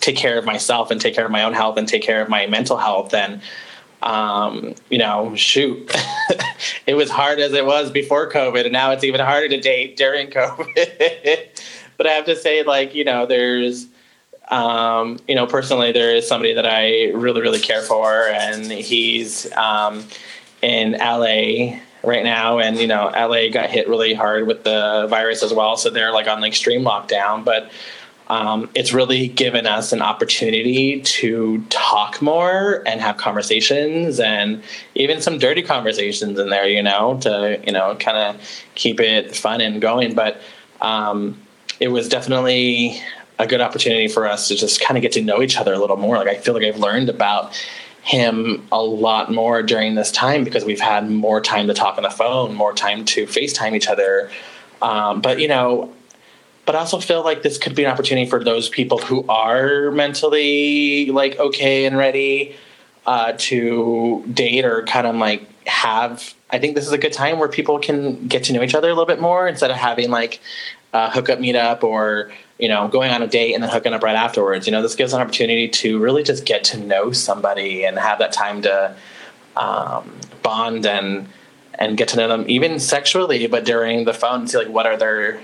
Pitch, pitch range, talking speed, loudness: 115 Hz, 110-140 Hz, 200 wpm, -17 LUFS